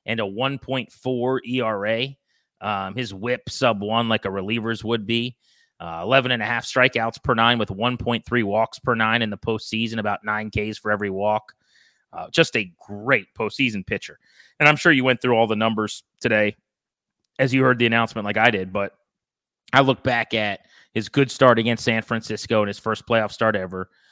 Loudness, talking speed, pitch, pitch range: -22 LUFS, 190 wpm, 115 Hz, 110-125 Hz